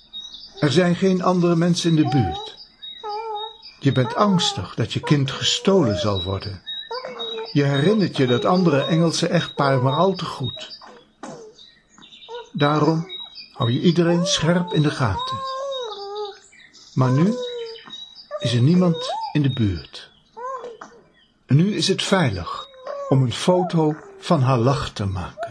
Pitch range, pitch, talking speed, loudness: 140-225 Hz, 175 Hz, 130 wpm, -20 LUFS